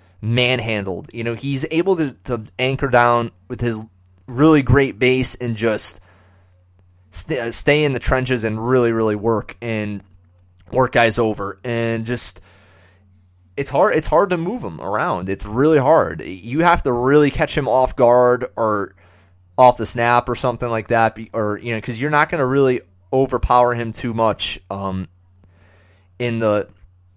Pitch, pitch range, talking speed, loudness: 115 Hz, 95-125 Hz, 165 wpm, -18 LUFS